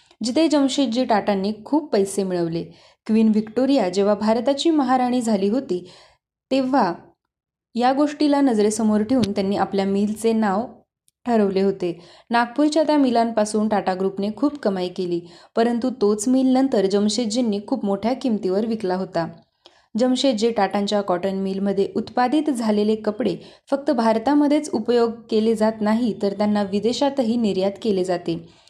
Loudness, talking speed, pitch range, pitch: -21 LUFS, 130 wpm, 200-255 Hz, 220 Hz